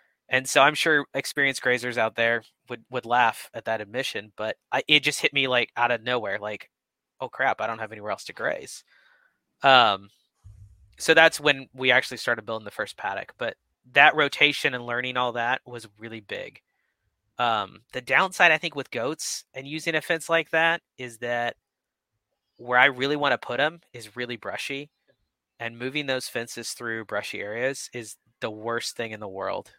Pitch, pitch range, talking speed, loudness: 125 Hz, 115-140 Hz, 190 wpm, -24 LUFS